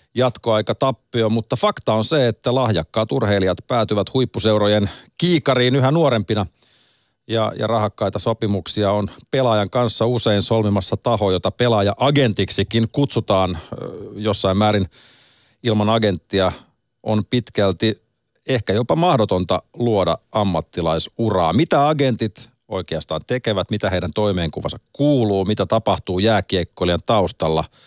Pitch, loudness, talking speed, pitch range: 110 Hz, -19 LUFS, 110 wpm, 100-120 Hz